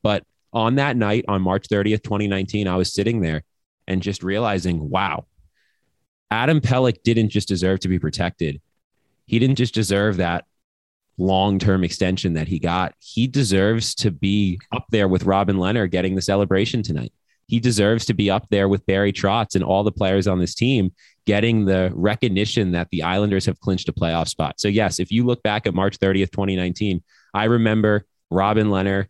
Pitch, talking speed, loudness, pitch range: 100 Hz, 180 wpm, -20 LUFS, 95-110 Hz